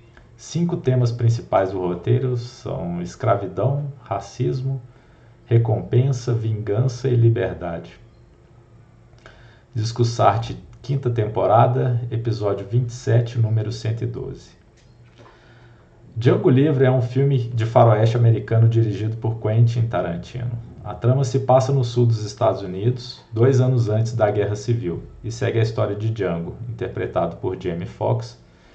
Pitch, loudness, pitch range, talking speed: 115 Hz, -21 LUFS, 110-125 Hz, 115 wpm